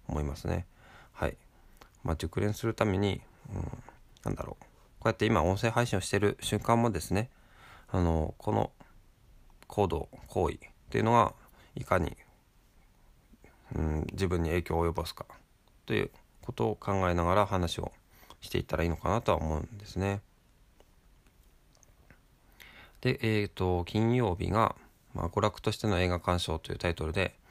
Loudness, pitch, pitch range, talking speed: -31 LUFS, 95 Hz, 85-105 Hz, 290 characters per minute